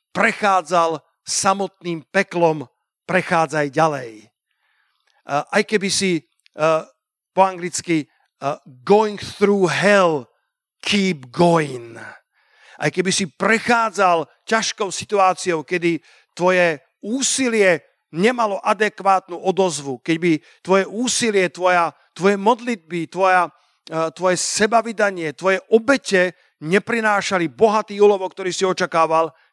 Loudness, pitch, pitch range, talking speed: -19 LUFS, 185 Hz, 165-205 Hz, 90 wpm